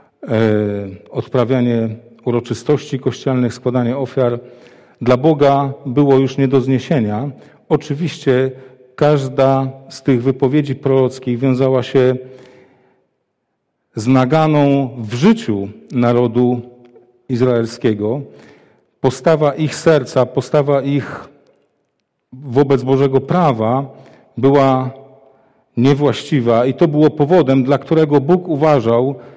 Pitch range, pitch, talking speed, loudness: 125-140 Hz, 135 Hz, 90 wpm, -15 LUFS